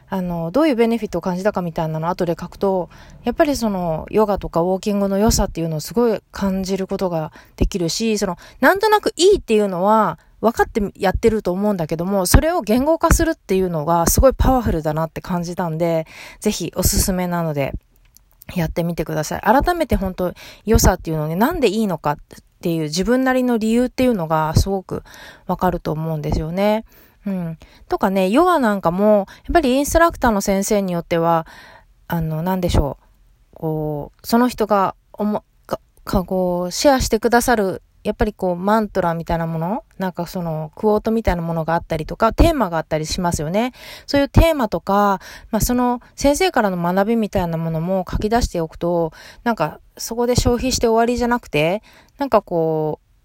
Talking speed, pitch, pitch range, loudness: 410 characters per minute, 195 Hz, 170-230 Hz, -19 LUFS